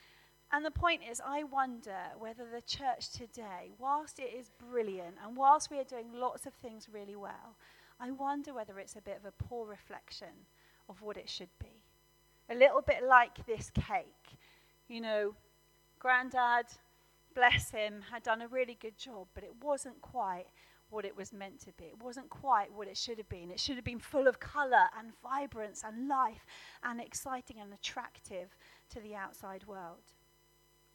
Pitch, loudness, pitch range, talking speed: 235 Hz, -34 LUFS, 205-260 Hz, 180 wpm